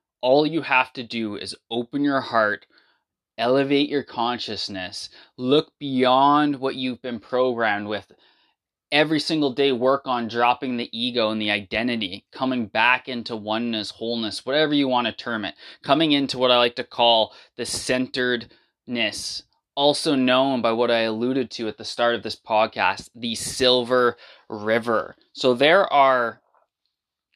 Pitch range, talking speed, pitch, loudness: 115-135 Hz, 150 wpm, 125 Hz, -22 LUFS